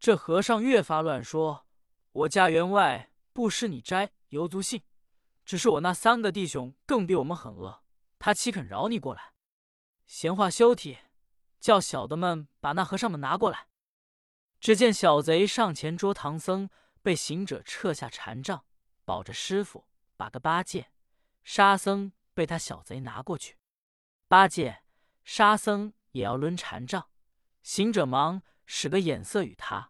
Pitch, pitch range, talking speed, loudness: 190 Hz, 160-210 Hz, 215 characters per minute, -27 LUFS